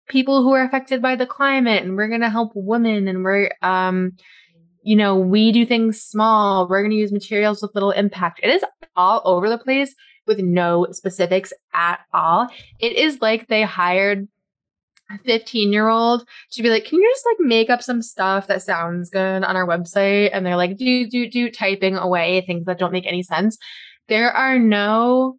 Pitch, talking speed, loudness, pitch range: 210 Hz, 200 wpm, -18 LUFS, 185-235 Hz